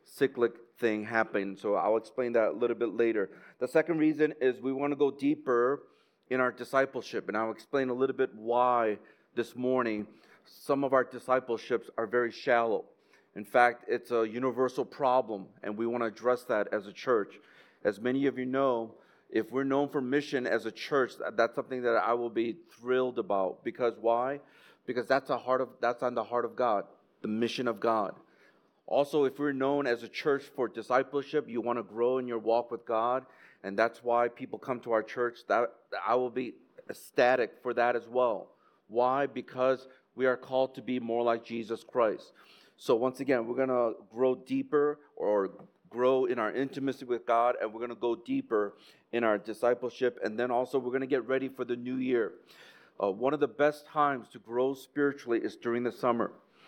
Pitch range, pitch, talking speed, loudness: 115-135 Hz, 125 Hz, 200 wpm, -31 LUFS